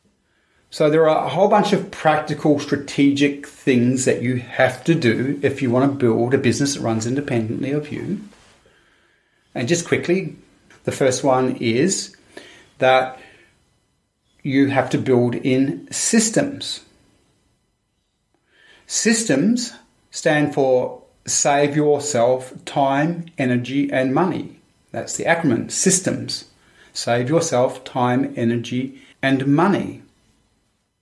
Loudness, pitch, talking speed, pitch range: -19 LUFS, 135 Hz, 115 wpm, 125-150 Hz